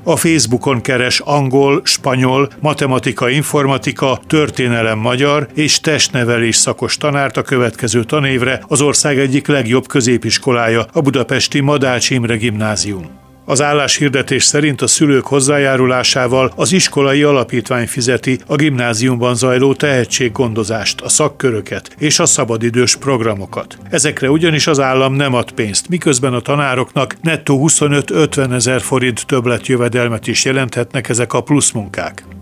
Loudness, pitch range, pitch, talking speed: -13 LUFS, 120-145 Hz, 130 Hz, 125 wpm